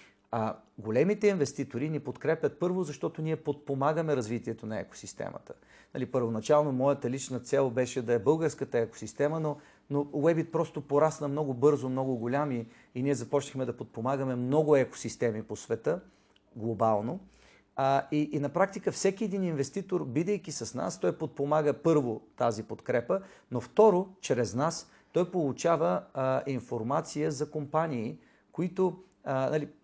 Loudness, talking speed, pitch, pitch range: -30 LUFS, 140 wpm, 145 Hz, 120-155 Hz